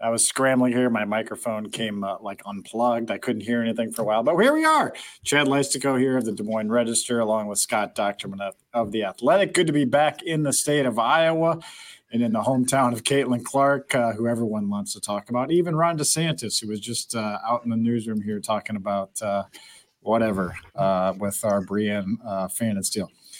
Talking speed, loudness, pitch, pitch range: 215 wpm, -23 LUFS, 115 Hz, 105-135 Hz